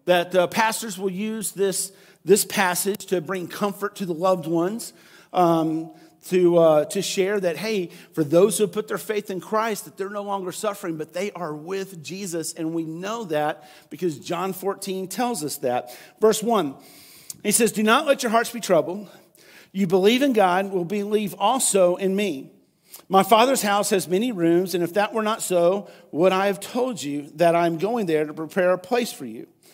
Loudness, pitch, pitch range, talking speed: -22 LUFS, 190 Hz, 175-210 Hz, 200 wpm